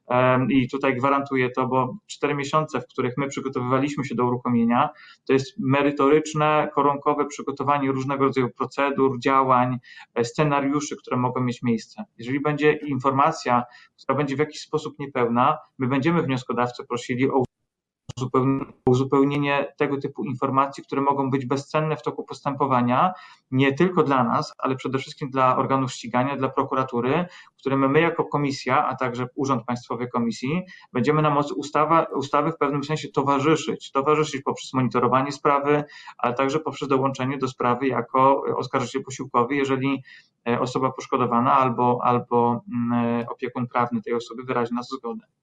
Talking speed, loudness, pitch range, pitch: 140 wpm, -23 LUFS, 125-145 Hz, 135 Hz